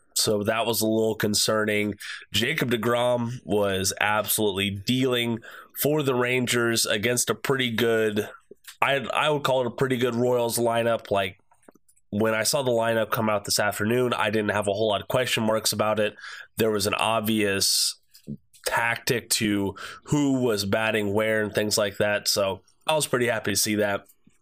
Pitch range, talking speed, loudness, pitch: 105-120 Hz, 175 wpm, -24 LUFS, 110 Hz